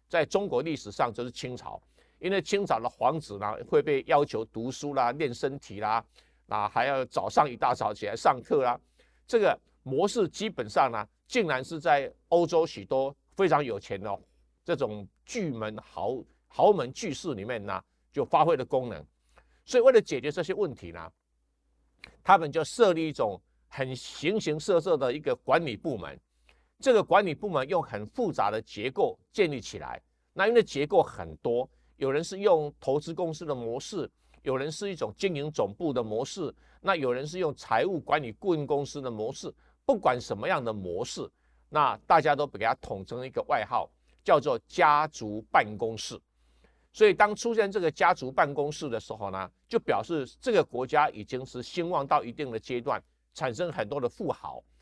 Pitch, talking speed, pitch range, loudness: 145 Hz, 265 characters per minute, 110-175 Hz, -28 LUFS